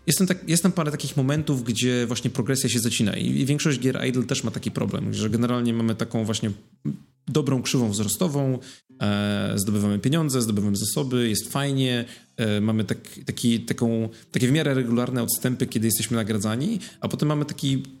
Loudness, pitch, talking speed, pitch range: -24 LUFS, 125 Hz, 175 wpm, 115-140 Hz